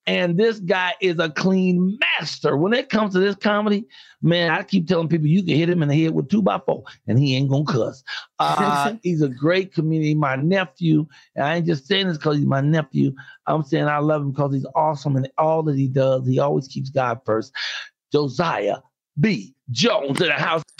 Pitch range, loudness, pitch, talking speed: 145-180 Hz, -21 LUFS, 160 Hz, 215 wpm